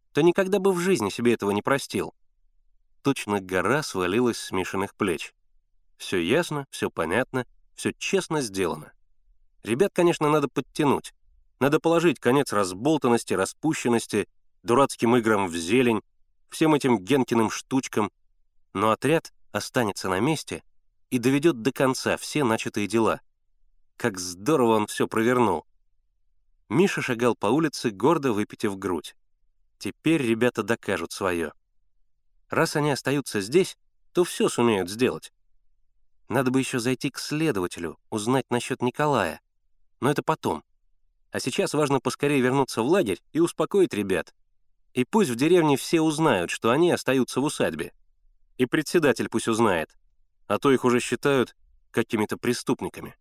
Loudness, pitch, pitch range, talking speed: -25 LUFS, 120 Hz, 105-145 Hz, 135 wpm